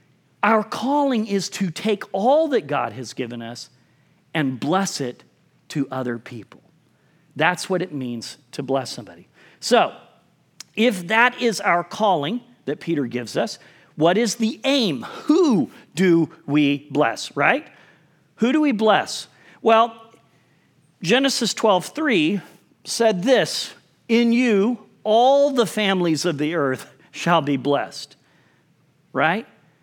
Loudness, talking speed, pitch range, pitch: -21 LUFS, 130 wpm, 145-230 Hz, 175 Hz